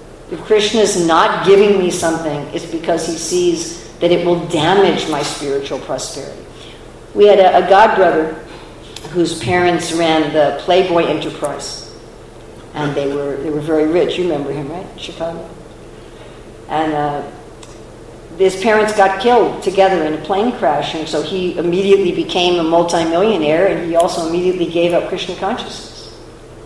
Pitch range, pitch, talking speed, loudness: 145-185 Hz, 170 Hz, 150 wpm, -15 LUFS